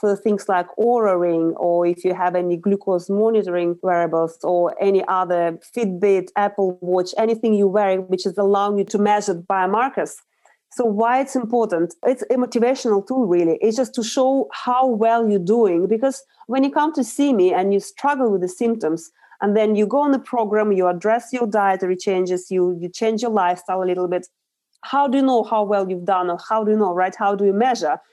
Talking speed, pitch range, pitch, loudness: 205 wpm, 180-230 Hz, 200 Hz, -19 LUFS